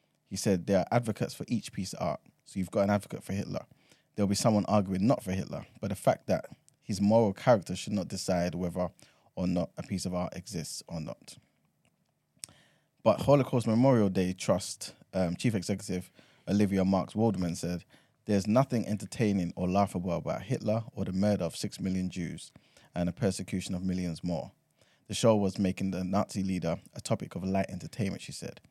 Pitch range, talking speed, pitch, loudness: 90-105 Hz, 190 wpm, 95 Hz, -31 LUFS